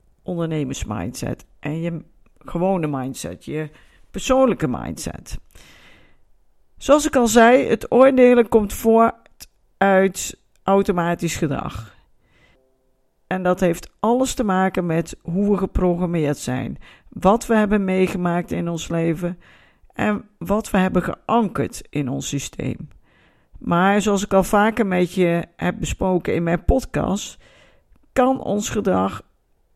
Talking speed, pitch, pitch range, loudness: 125 wpm, 185 Hz, 165-210 Hz, -20 LUFS